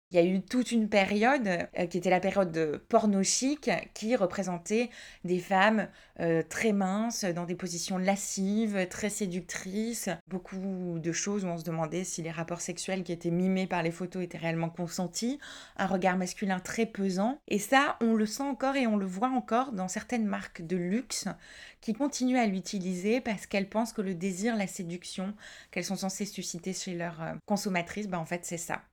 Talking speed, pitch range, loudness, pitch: 195 wpm, 180-215 Hz, -31 LUFS, 190 Hz